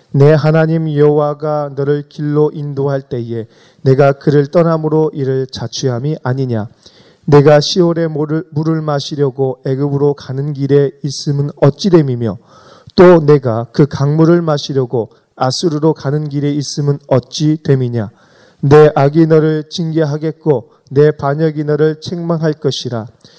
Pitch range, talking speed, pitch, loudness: 135-155 Hz, 280 characters per minute, 145 Hz, -13 LUFS